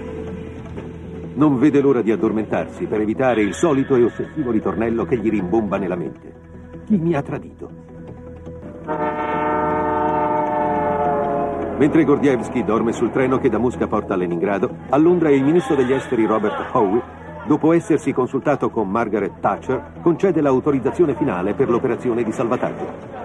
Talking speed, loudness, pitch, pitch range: 135 wpm, -19 LUFS, 140 Hz, 90-150 Hz